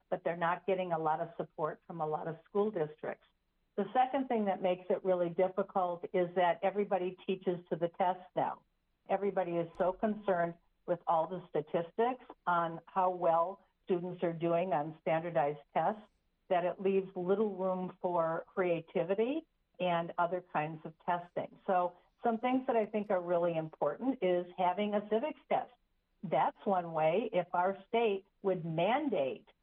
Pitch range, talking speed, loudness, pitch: 170-195 Hz, 165 wpm, -34 LUFS, 180 Hz